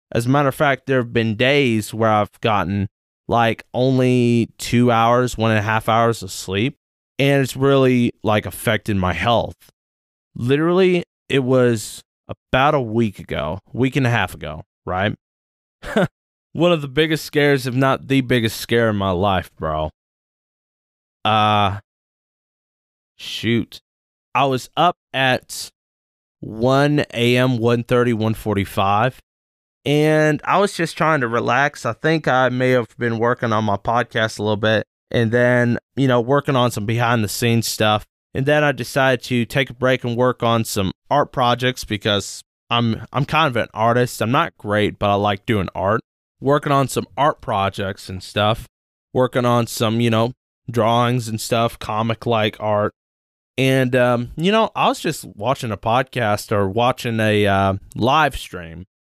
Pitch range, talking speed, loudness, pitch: 105-130 Hz, 160 wpm, -19 LUFS, 115 Hz